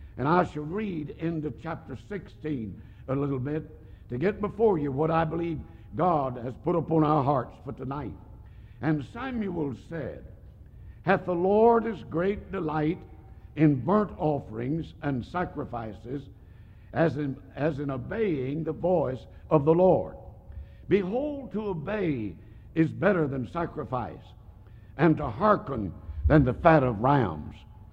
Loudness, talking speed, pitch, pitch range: -27 LUFS, 140 wpm, 145 Hz, 110-165 Hz